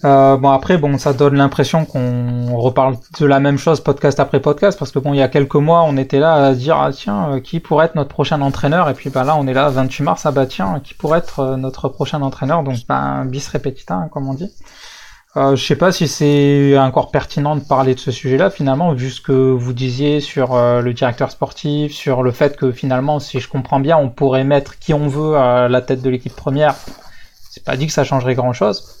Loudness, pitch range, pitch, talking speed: -15 LUFS, 130-150 Hz, 140 Hz, 245 wpm